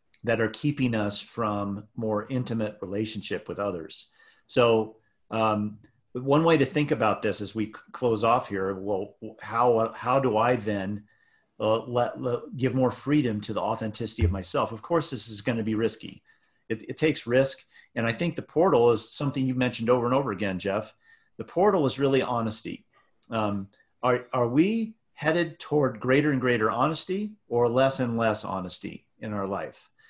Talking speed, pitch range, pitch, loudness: 180 wpm, 110-135 Hz, 120 Hz, -27 LUFS